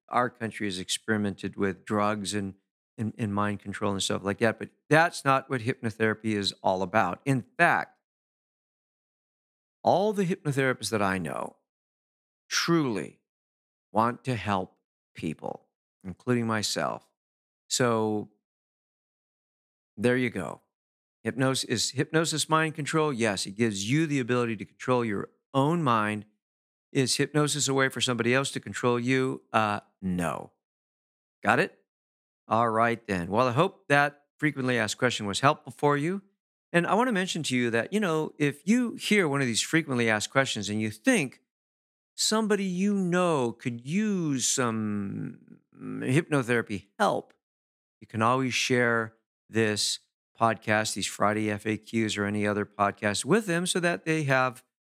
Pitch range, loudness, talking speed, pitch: 105-140 Hz, -27 LUFS, 150 wpm, 115 Hz